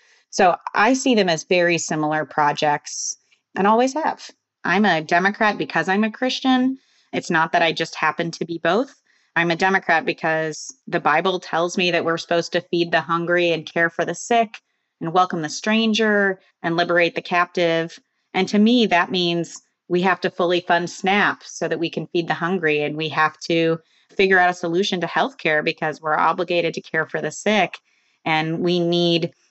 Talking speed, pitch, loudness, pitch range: 190 wpm, 170 Hz, -20 LUFS, 165-190 Hz